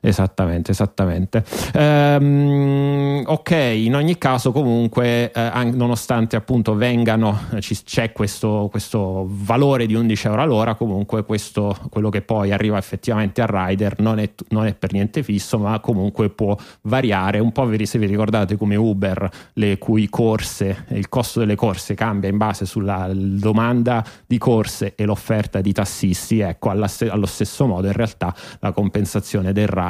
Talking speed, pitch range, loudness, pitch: 155 wpm, 100-115 Hz, -19 LUFS, 110 Hz